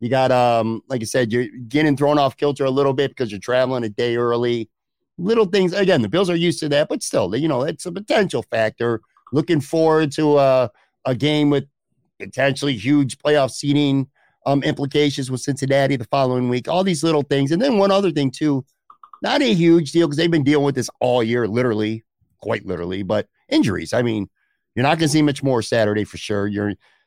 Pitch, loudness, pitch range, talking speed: 135 Hz, -19 LUFS, 120-150 Hz, 210 wpm